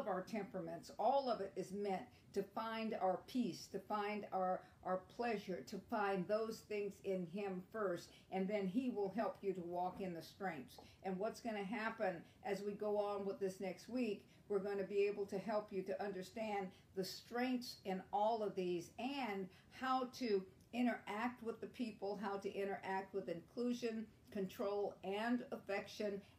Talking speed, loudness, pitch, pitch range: 175 wpm, -44 LUFS, 200 Hz, 190-220 Hz